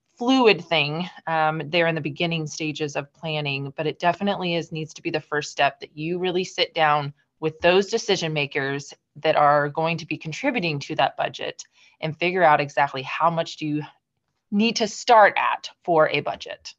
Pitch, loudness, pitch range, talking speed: 160 Hz, -23 LUFS, 150-180 Hz, 190 wpm